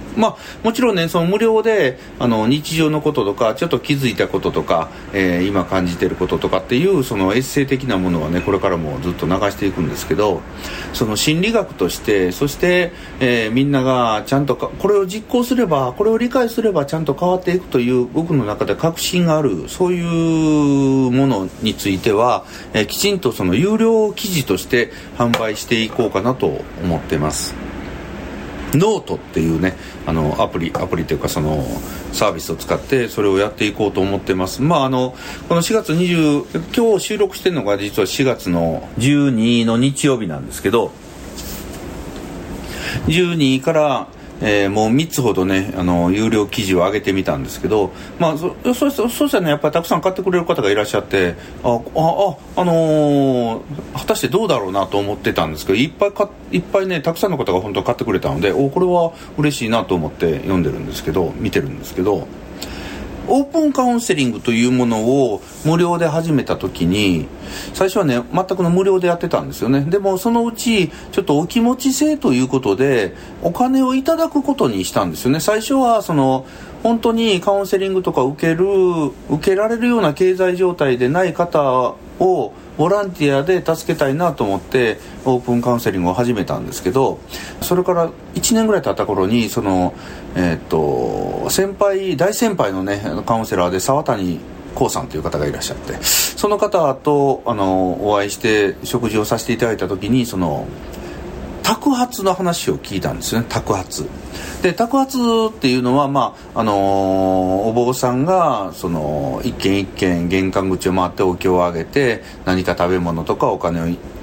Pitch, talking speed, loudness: 130 Hz, 360 characters per minute, -17 LUFS